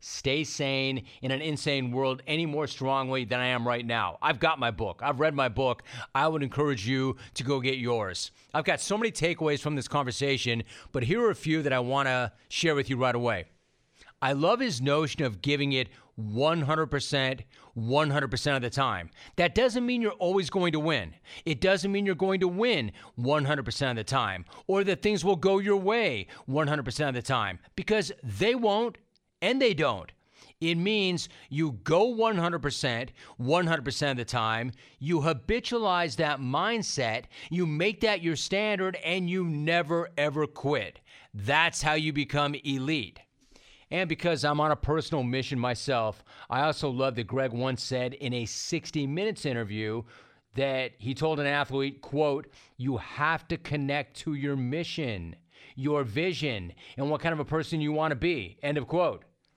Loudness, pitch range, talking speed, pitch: -28 LUFS, 130-165 Hz, 175 wpm, 145 Hz